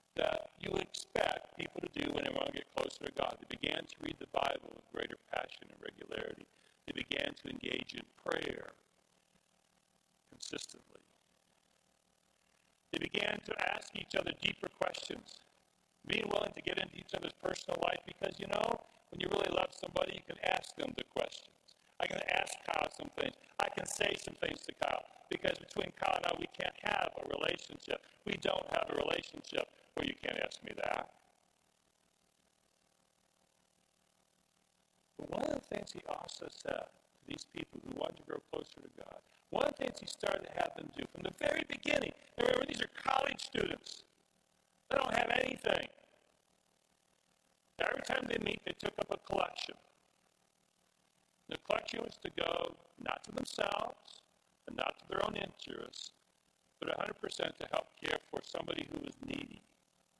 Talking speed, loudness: 170 wpm, -39 LUFS